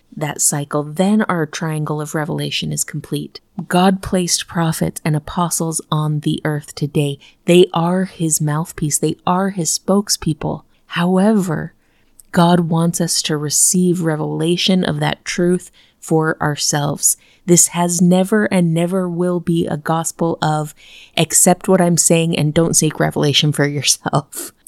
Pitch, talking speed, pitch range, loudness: 165 Hz, 140 wpm, 150-180 Hz, -16 LUFS